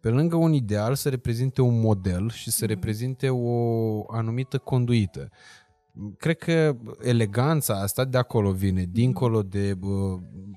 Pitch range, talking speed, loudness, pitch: 105-130 Hz, 135 wpm, -25 LUFS, 115 Hz